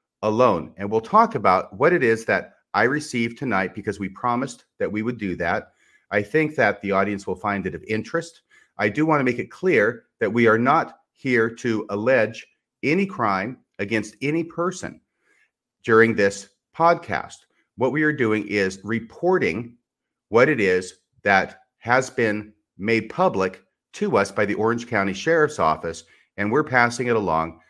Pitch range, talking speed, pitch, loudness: 100-130 Hz, 170 wpm, 115 Hz, -22 LUFS